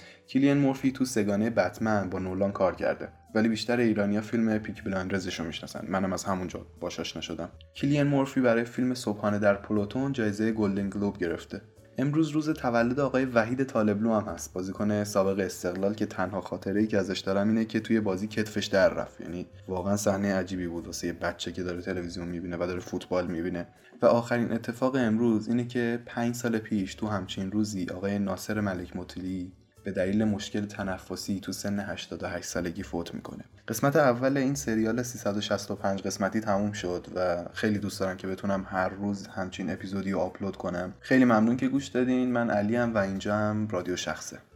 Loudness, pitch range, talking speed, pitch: -29 LUFS, 95-115 Hz, 180 wpm, 100 Hz